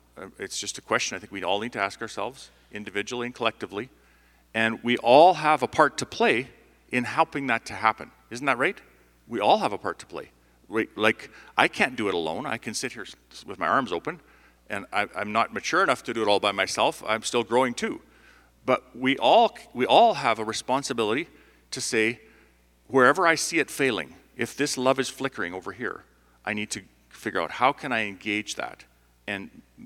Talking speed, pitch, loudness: 200 wpm, 110 Hz, -25 LUFS